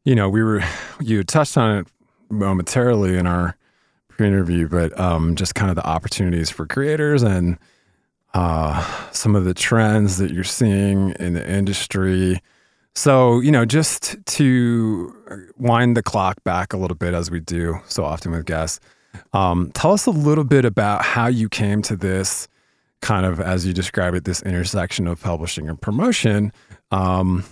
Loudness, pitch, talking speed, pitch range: -19 LUFS, 95 Hz, 170 wpm, 90-110 Hz